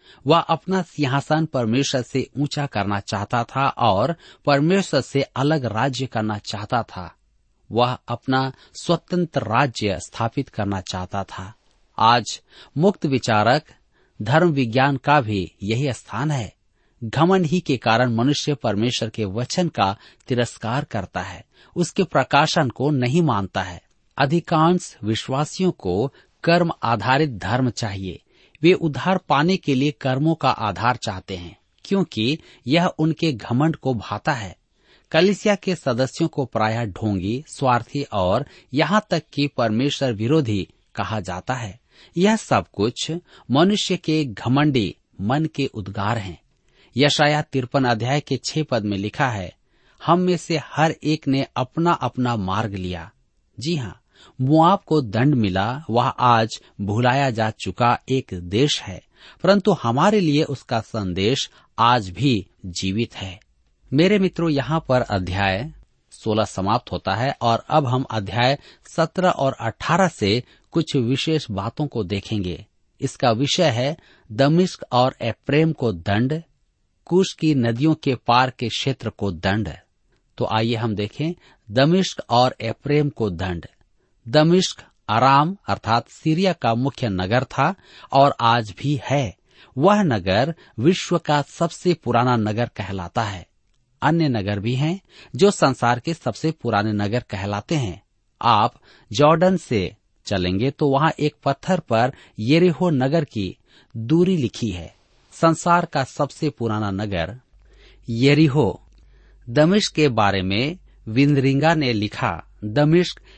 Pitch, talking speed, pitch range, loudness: 130 Hz, 135 wpm, 110-155 Hz, -21 LUFS